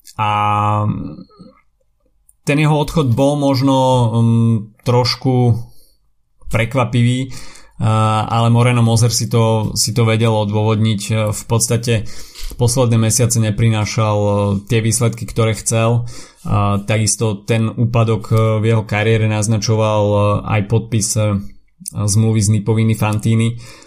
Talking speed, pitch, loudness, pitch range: 100 wpm, 115 Hz, -15 LUFS, 105-120 Hz